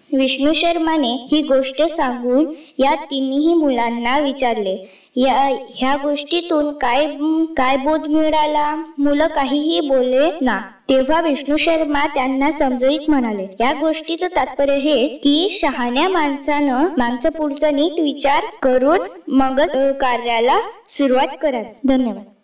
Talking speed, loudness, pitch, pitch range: 110 wpm, -17 LUFS, 285 Hz, 265-310 Hz